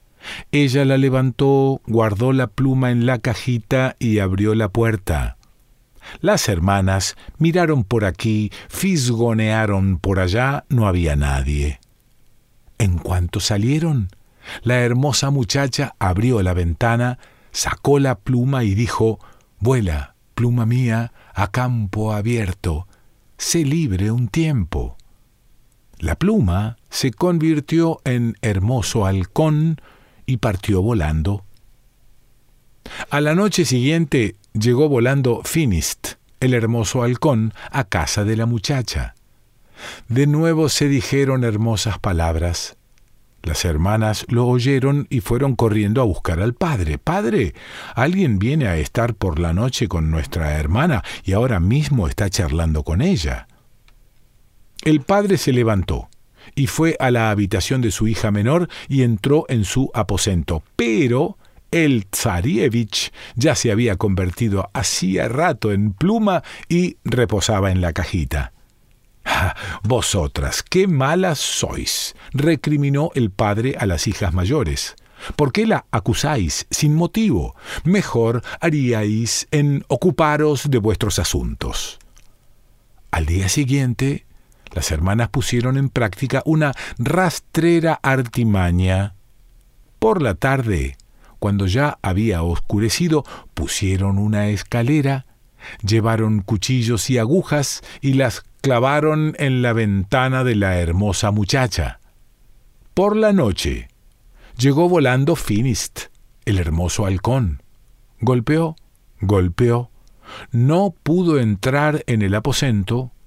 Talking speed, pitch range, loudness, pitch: 115 wpm, 100-135 Hz, -19 LUFS, 120 Hz